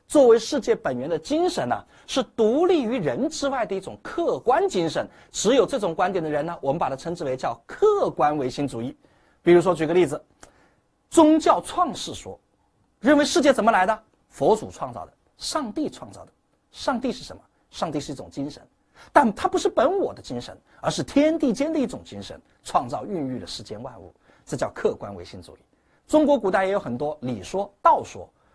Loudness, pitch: -23 LUFS, 260 Hz